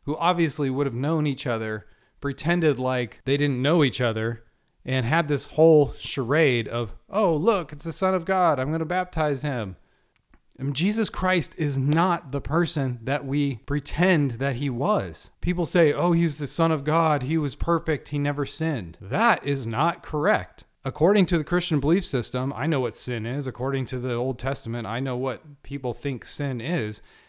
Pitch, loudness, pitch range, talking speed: 145 Hz, -24 LUFS, 130-165 Hz, 190 wpm